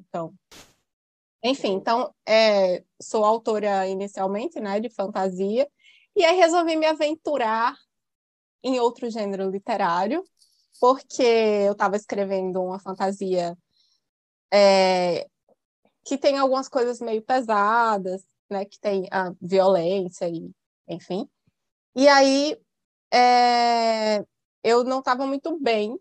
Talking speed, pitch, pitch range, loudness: 110 wpm, 215 Hz, 190-260 Hz, -22 LUFS